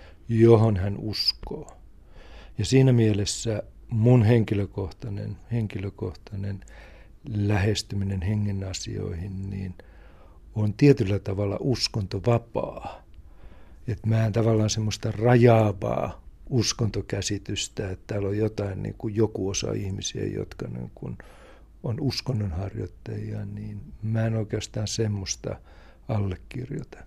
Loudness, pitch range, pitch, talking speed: -26 LUFS, 95-110 Hz, 105 Hz, 95 wpm